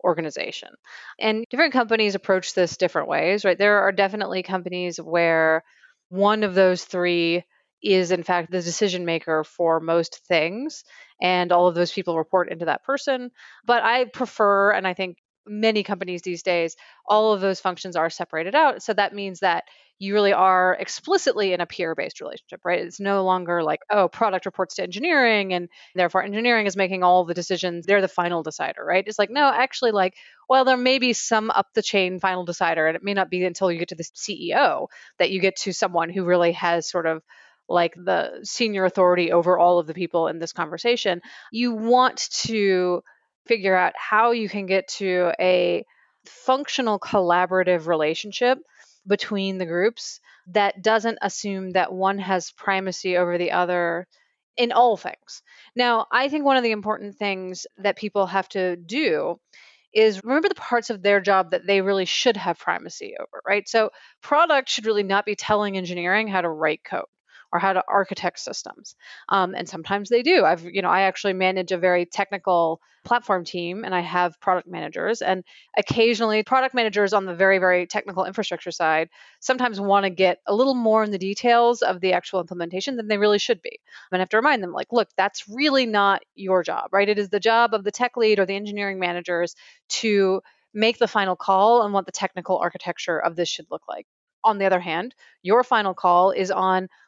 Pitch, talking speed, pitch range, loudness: 195 Hz, 195 wpm, 180-220 Hz, -22 LUFS